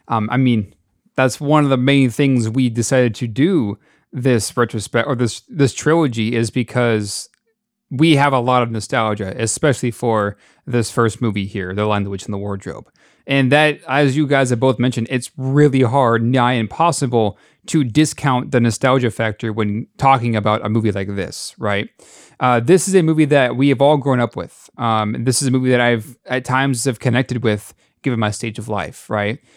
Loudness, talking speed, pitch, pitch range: -17 LUFS, 195 wpm, 125 Hz, 110-135 Hz